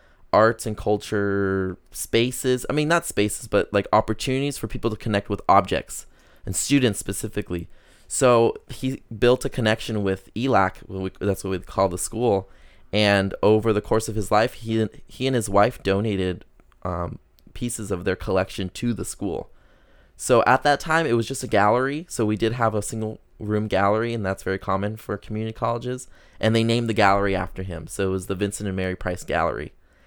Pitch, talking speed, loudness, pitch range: 105 Hz, 190 wpm, -23 LUFS, 95-115 Hz